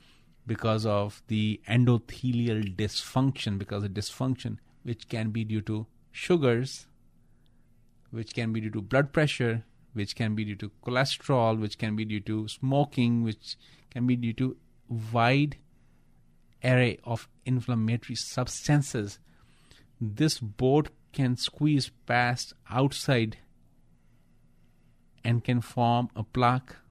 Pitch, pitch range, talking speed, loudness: 120 Hz, 110-130 Hz, 120 wpm, -29 LUFS